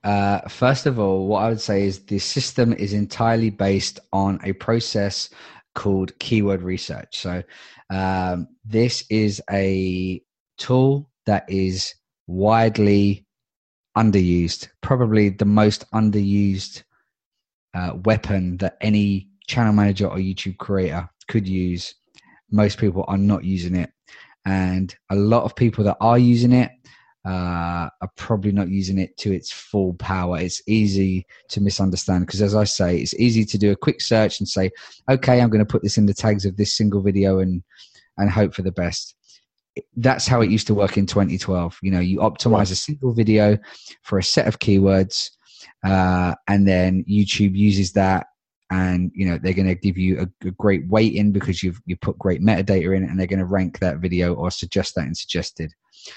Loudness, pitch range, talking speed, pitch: -20 LUFS, 95-105 Hz, 175 wpm, 100 Hz